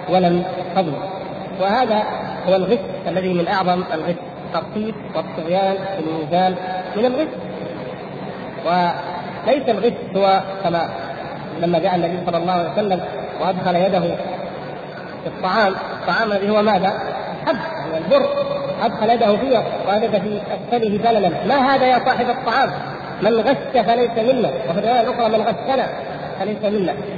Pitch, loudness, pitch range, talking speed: 195 Hz, -19 LUFS, 180-230 Hz, 130 wpm